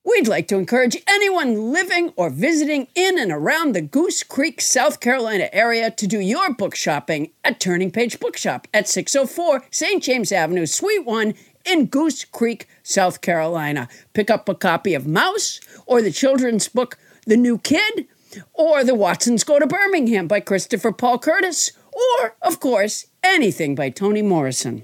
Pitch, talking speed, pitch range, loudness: 245 Hz, 165 wpm, 195-320 Hz, -19 LUFS